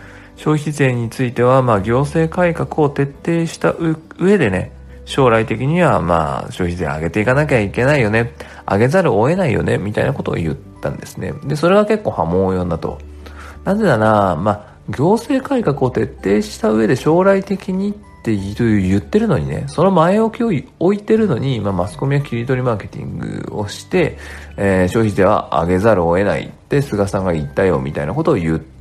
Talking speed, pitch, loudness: 375 characters per minute, 115 Hz, -16 LUFS